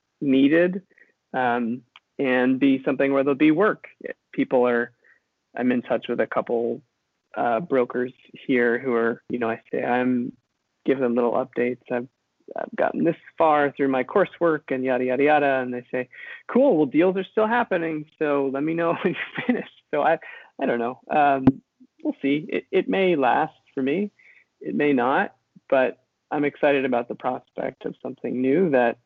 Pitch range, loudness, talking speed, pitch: 125-150 Hz, -23 LUFS, 180 wpm, 135 Hz